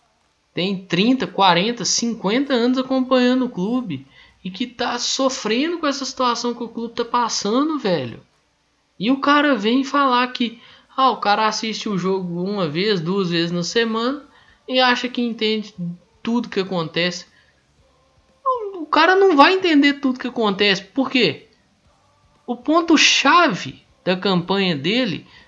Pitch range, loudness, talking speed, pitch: 195-260 Hz, -19 LUFS, 145 wpm, 235 Hz